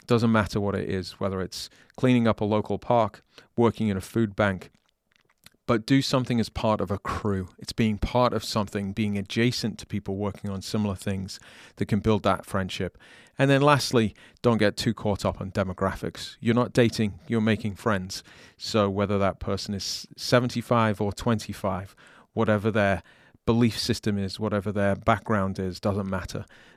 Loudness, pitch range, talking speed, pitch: -26 LUFS, 100-115 Hz, 175 wpm, 105 Hz